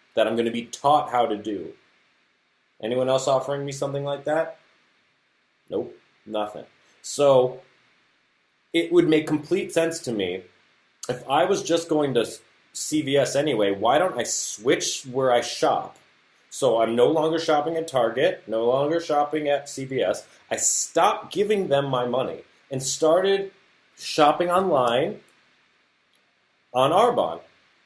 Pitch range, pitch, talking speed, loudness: 130-160 Hz, 145 Hz, 140 wpm, -23 LUFS